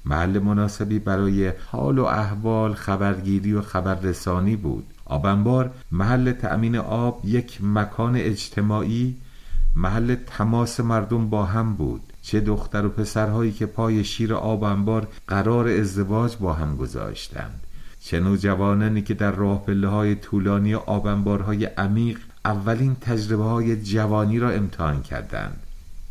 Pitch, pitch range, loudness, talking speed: 105 Hz, 100-110 Hz, -23 LUFS, 120 wpm